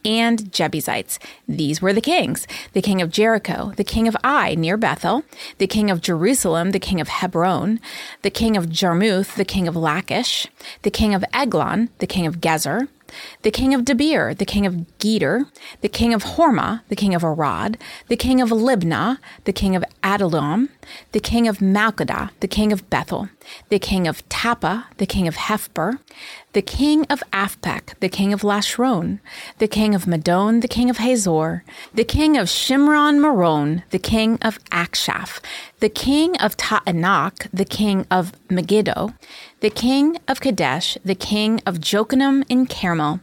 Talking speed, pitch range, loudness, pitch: 170 wpm, 185-235 Hz, -19 LUFS, 210 Hz